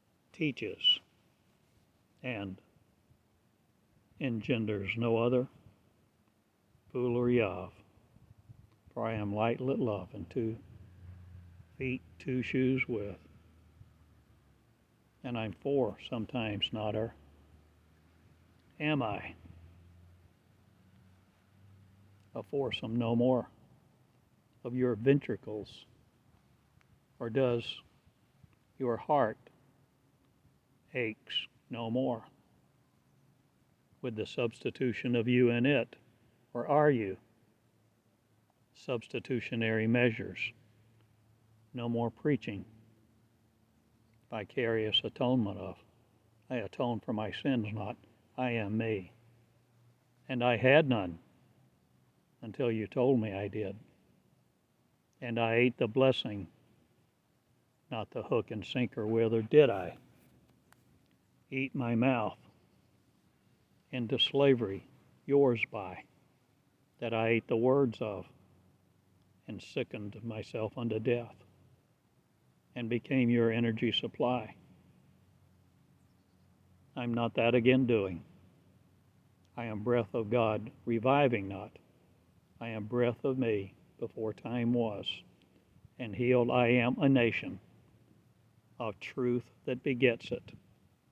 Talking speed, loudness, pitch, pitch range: 95 wpm, -32 LUFS, 115 Hz, 105-125 Hz